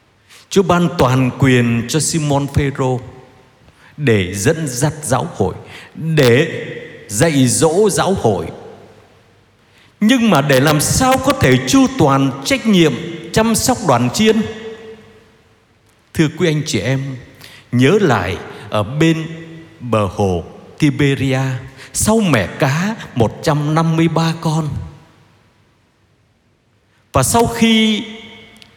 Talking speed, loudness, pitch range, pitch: 110 wpm, -15 LUFS, 115-165 Hz, 140 Hz